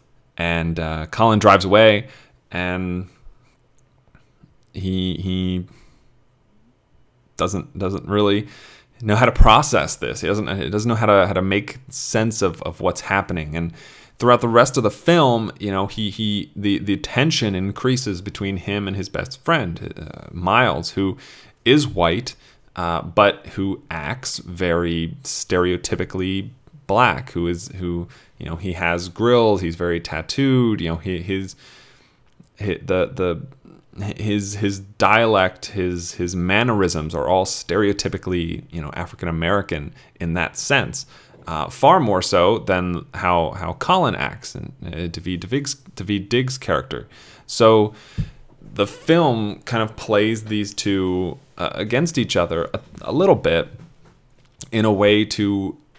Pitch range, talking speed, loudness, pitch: 90-110 Hz, 140 wpm, -20 LUFS, 100 Hz